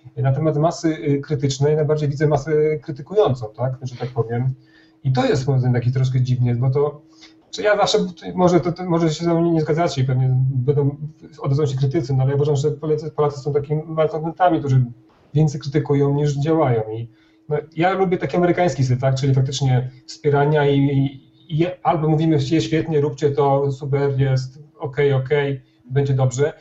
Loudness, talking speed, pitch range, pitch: -20 LUFS, 170 wpm, 135-155 Hz, 145 Hz